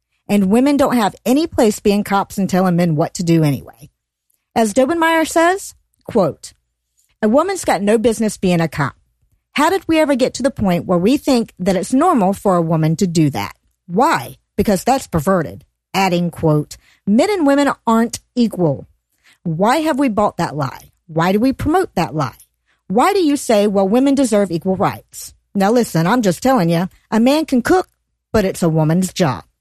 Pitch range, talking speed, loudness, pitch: 170-260 Hz, 190 wpm, -16 LUFS, 200 Hz